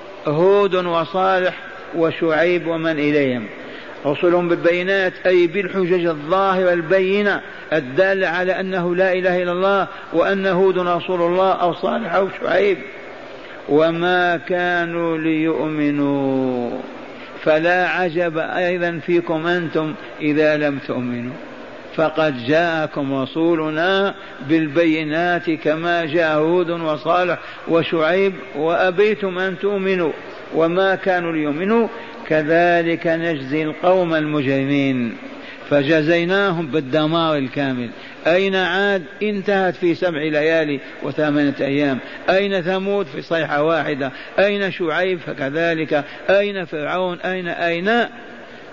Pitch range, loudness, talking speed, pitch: 155-185 Hz, -19 LUFS, 95 wpm, 170 Hz